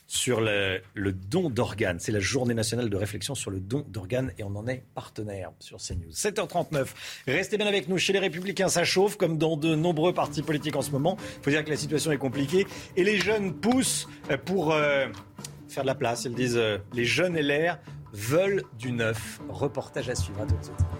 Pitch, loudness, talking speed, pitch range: 140 Hz, -27 LUFS, 210 wpm, 110-170 Hz